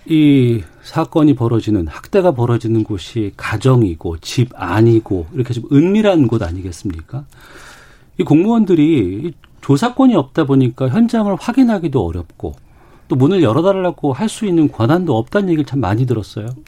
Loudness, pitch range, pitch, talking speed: -15 LUFS, 110-170 Hz, 130 Hz, 335 characters per minute